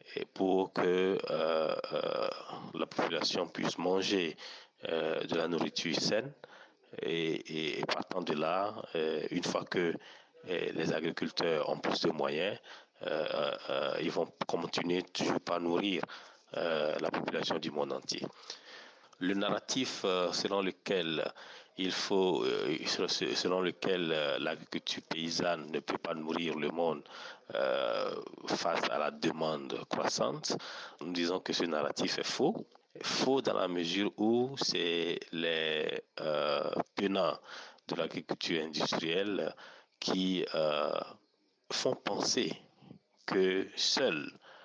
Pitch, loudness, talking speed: 95 Hz, -34 LUFS, 120 wpm